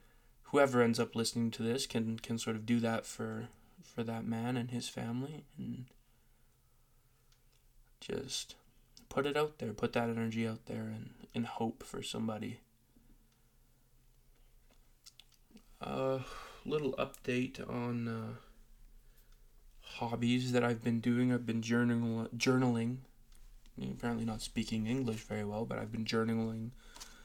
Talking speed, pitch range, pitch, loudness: 135 wpm, 115-125 Hz, 120 Hz, -36 LUFS